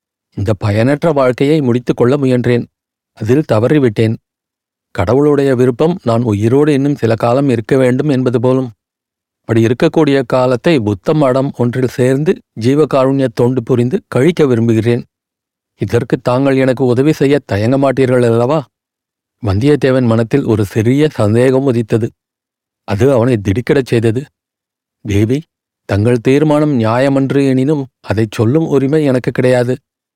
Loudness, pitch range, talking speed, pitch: -13 LUFS, 115-140 Hz, 115 wpm, 125 Hz